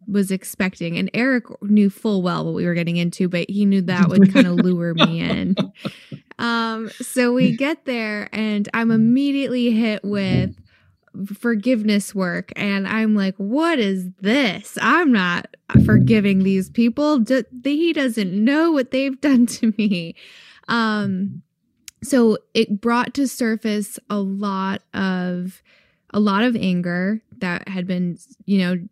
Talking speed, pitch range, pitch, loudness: 145 wpm, 195-240 Hz, 210 Hz, -19 LUFS